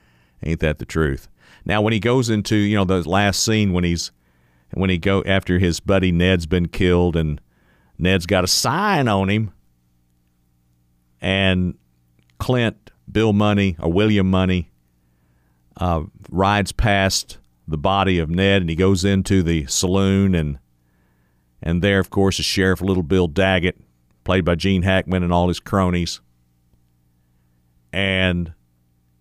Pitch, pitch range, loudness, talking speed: 90 Hz, 60-95 Hz, -19 LUFS, 145 wpm